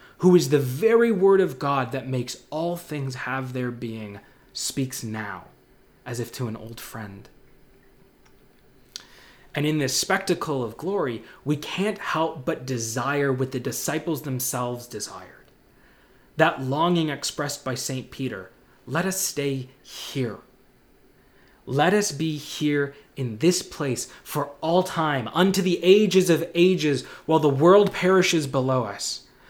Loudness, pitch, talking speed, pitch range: -24 LUFS, 140 Hz, 140 wpm, 125-170 Hz